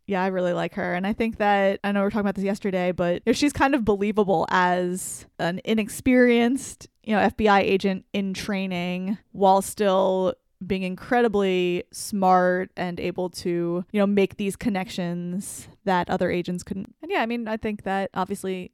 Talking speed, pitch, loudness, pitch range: 180 wpm, 195 Hz, -24 LUFS, 180-210 Hz